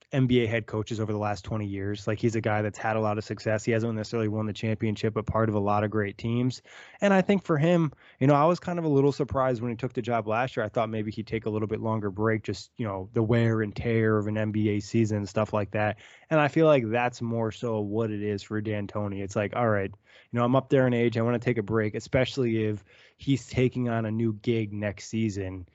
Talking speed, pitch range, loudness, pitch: 275 wpm, 105-120 Hz, -27 LUFS, 110 Hz